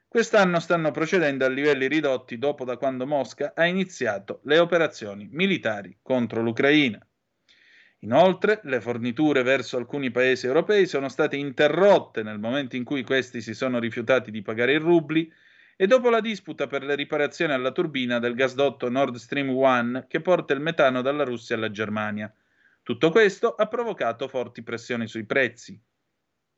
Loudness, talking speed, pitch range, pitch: -24 LUFS, 155 wpm, 120-160 Hz, 135 Hz